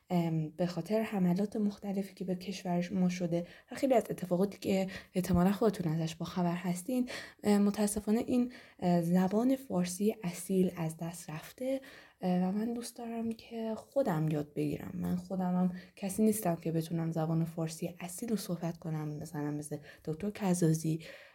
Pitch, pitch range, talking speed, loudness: 180 Hz, 170-210 Hz, 150 wpm, -34 LUFS